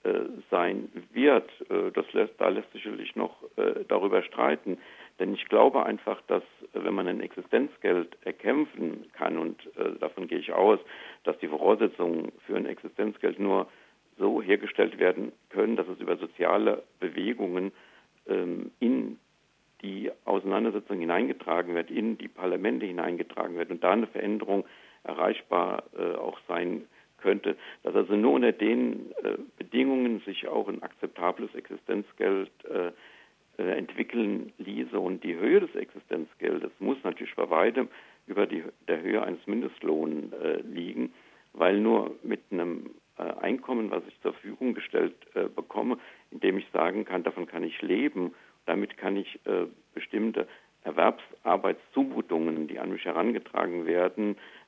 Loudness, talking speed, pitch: -29 LUFS, 140 wpm, 375 Hz